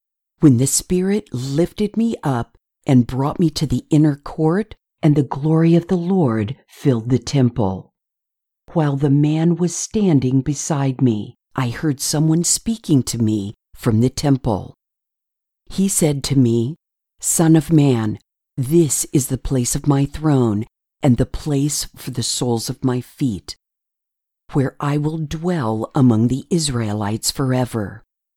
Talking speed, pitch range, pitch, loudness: 145 wpm, 125-160 Hz, 140 Hz, -18 LUFS